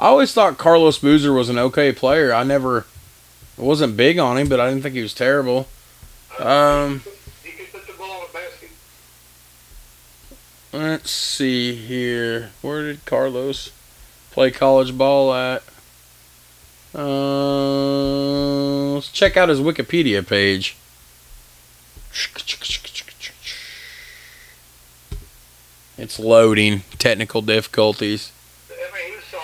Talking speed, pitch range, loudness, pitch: 90 wpm, 95-145 Hz, -18 LUFS, 130 Hz